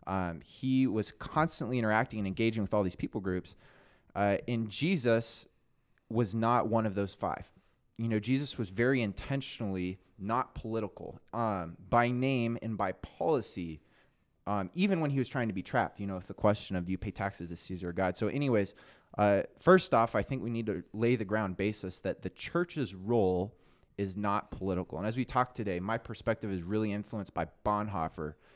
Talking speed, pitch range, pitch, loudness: 190 wpm, 95-120 Hz, 105 Hz, -33 LUFS